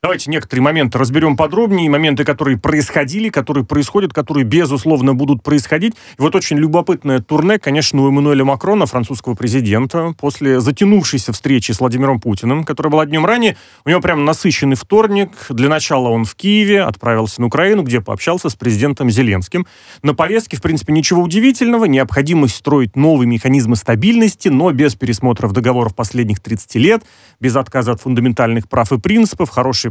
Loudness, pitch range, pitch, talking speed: -14 LUFS, 125-165 Hz, 145 Hz, 160 wpm